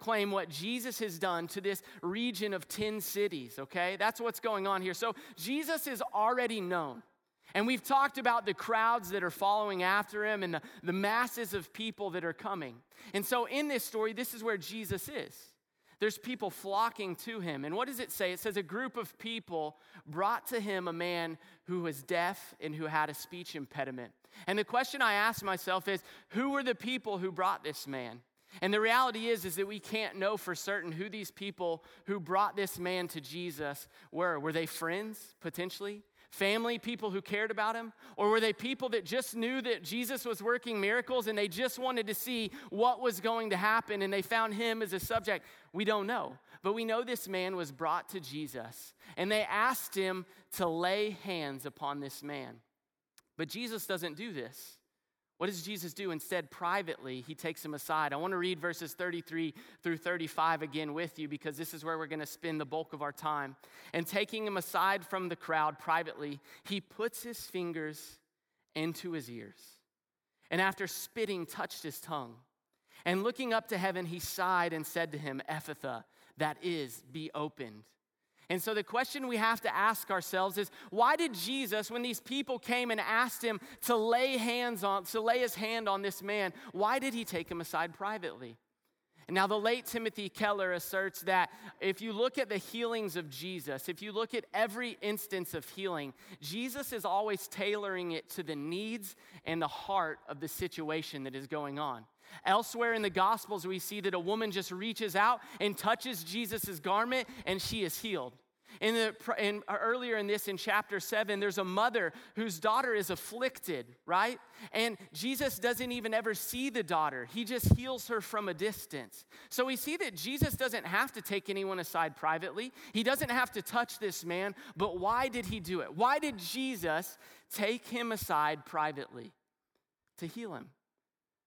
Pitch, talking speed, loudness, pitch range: 200 Hz, 195 wpm, -35 LUFS, 170-225 Hz